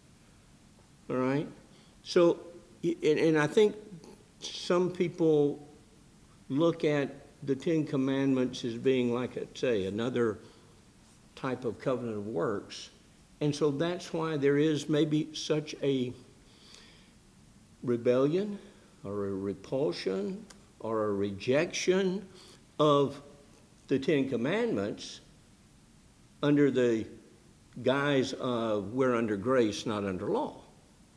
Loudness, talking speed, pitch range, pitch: -30 LUFS, 105 wpm, 115-160 Hz, 140 Hz